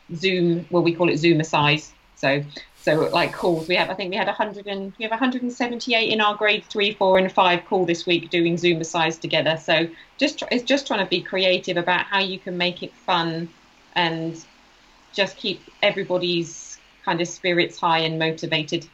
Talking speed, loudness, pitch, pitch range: 205 wpm, -22 LUFS, 180 Hz, 165-200 Hz